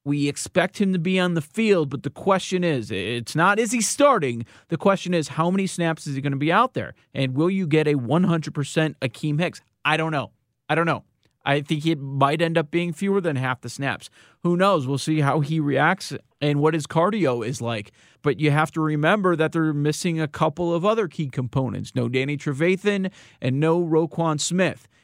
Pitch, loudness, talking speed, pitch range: 155 Hz, -23 LUFS, 215 wpm, 140-175 Hz